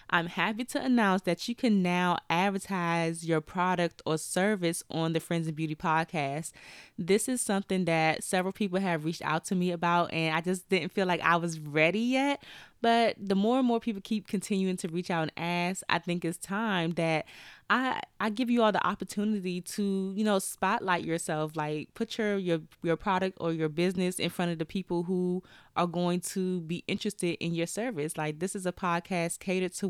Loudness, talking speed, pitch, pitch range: -30 LUFS, 205 wpm, 180 Hz, 170-200 Hz